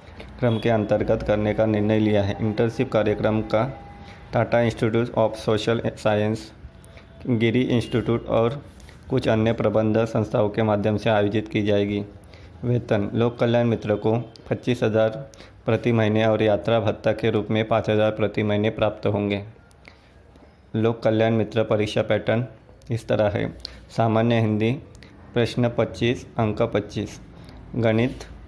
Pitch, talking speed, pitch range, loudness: 110 Hz, 135 wpm, 105-115 Hz, -23 LUFS